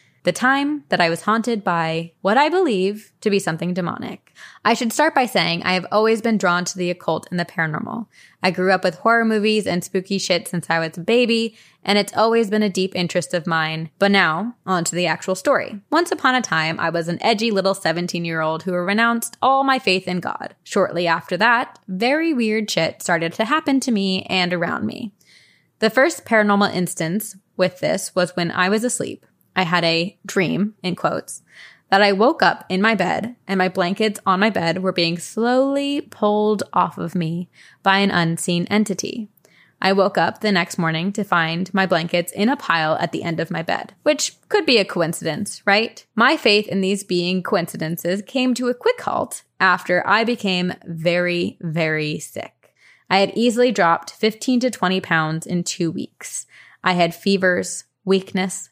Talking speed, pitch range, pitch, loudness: 195 wpm, 175-220 Hz, 190 Hz, -19 LUFS